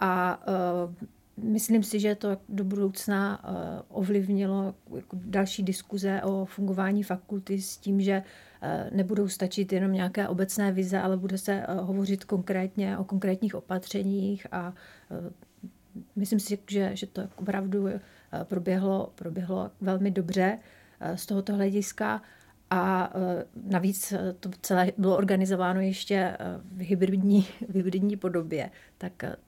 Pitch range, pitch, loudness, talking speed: 185-200 Hz, 195 Hz, -29 LUFS, 140 wpm